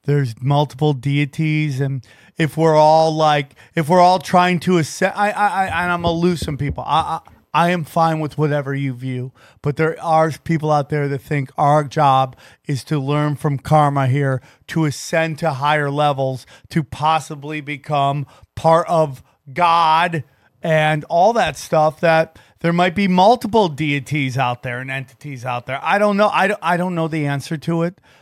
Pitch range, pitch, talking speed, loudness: 140-165 Hz, 150 Hz, 185 wpm, -18 LUFS